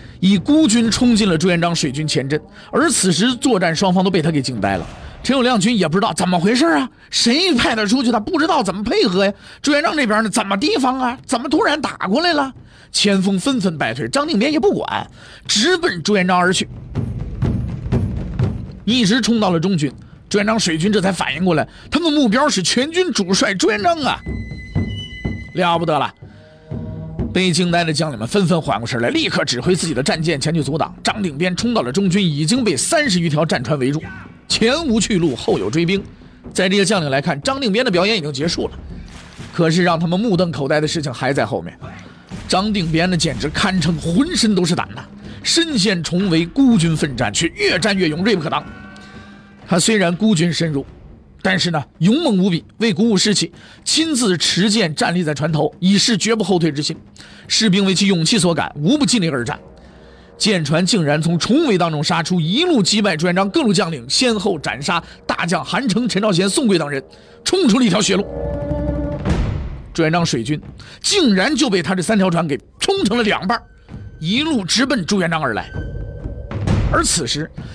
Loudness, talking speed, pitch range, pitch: -17 LUFS, 285 characters per minute, 165-225 Hz, 190 Hz